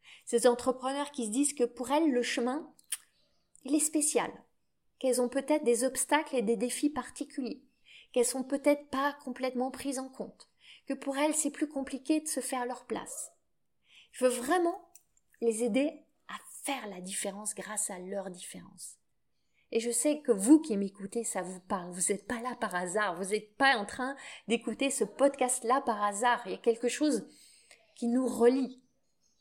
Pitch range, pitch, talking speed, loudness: 230-275 Hz, 255 Hz, 180 wpm, -31 LUFS